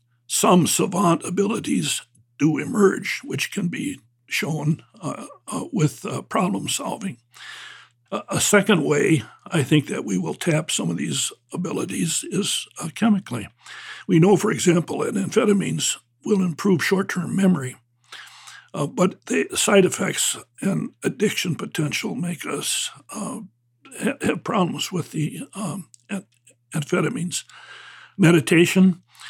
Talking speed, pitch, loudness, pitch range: 130 wpm, 175 Hz, -22 LUFS, 145-195 Hz